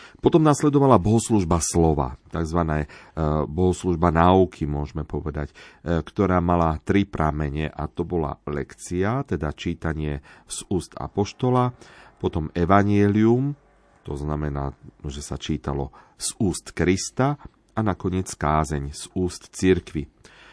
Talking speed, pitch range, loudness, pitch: 110 wpm, 75-100 Hz, -23 LUFS, 85 Hz